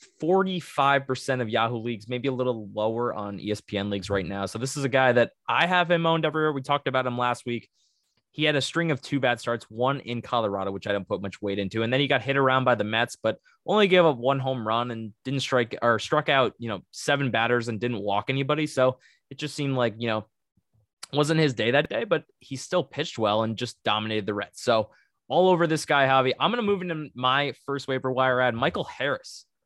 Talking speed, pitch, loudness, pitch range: 240 wpm, 130 Hz, -25 LUFS, 115-140 Hz